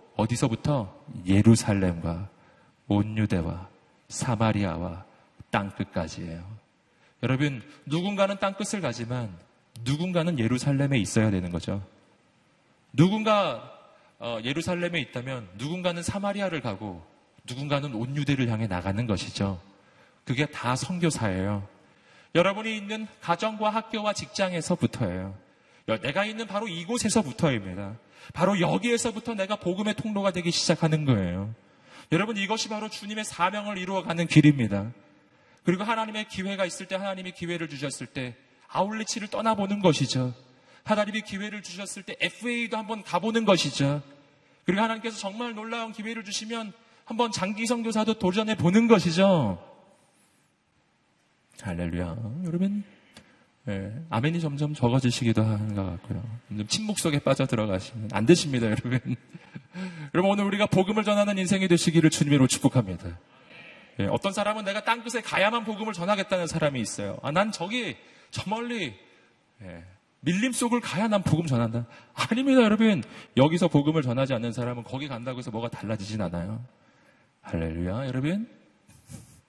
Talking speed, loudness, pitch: 335 characters per minute, -27 LUFS, 155 Hz